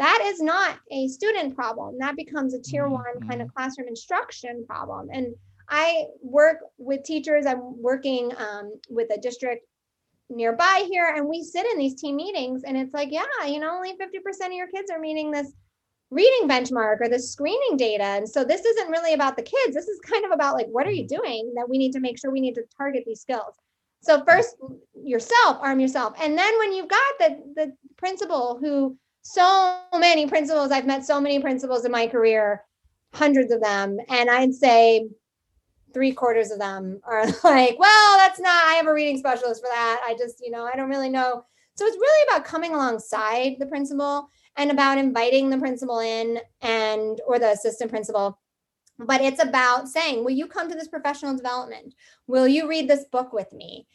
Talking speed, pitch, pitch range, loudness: 200 wpm, 270 Hz, 240-315 Hz, -22 LUFS